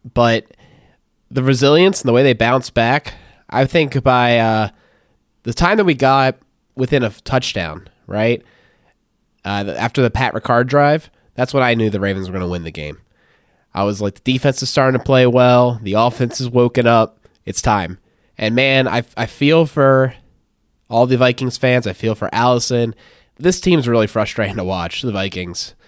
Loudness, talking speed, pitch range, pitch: -16 LUFS, 185 wpm, 110-130 Hz, 120 Hz